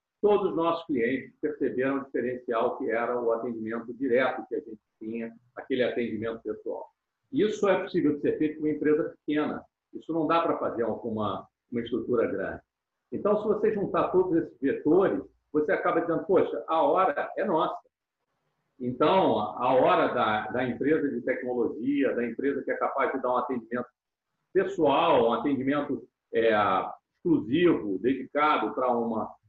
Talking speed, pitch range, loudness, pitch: 160 wpm, 120-165 Hz, -27 LUFS, 145 Hz